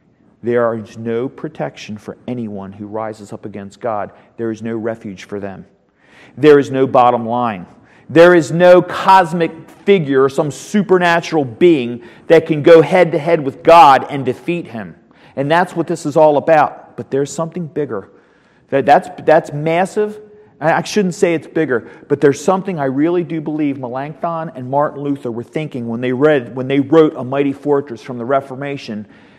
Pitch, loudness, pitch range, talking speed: 140 Hz, -14 LUFS, 120-165 Hz, 170 wpm